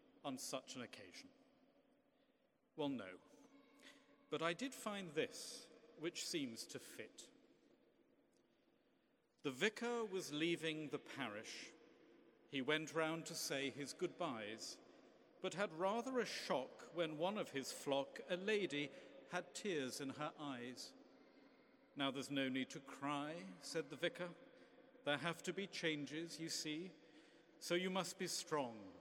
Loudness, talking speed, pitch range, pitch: -45 LUFS, 135 wpm, 150-215 Hz, 170 Hz